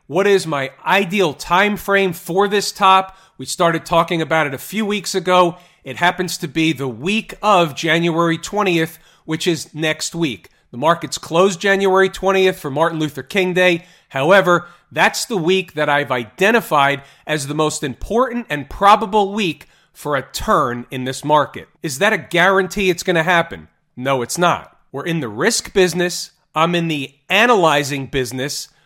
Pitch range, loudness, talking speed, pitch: 150-190 Hz, -17 LUFS, 170 wpm, 175 Hz